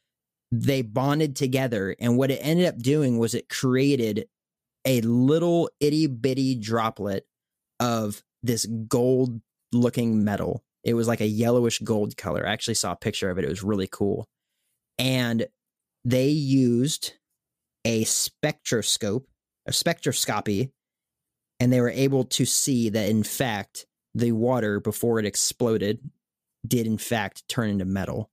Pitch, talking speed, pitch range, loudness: 120 Hz, 140 wpm, 110-130 Hz, -25 LUFS